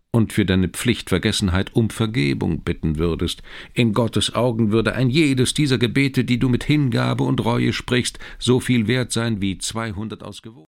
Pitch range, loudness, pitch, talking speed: 100-125 Hz, -20 LUFS, 115 Hz, 170 wpm